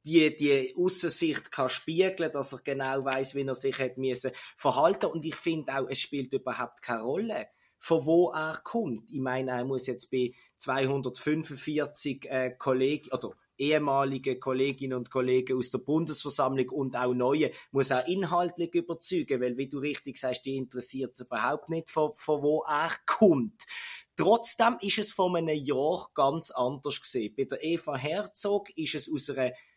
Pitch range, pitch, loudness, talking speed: 130-160 Hz, 140 Hz, -30 LUFS, 160 wpm